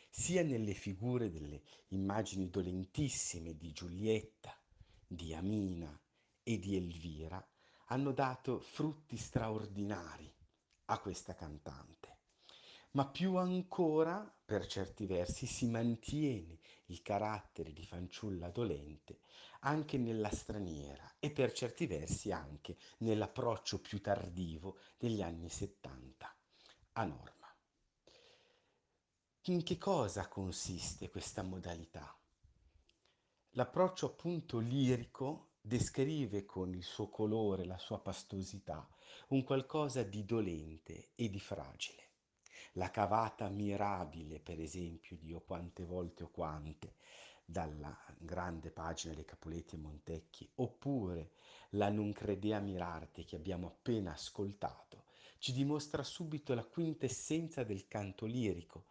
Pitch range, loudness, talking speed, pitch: 85-120 Hz, -41 LUFS, 110 wpm, 100 Hz